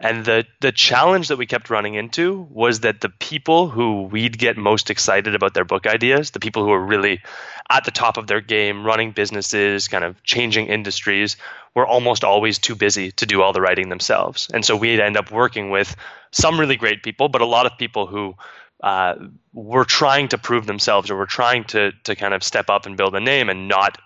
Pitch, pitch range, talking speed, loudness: 110 Hz, 100-120 Hz, 220 wpm, -18 LUFS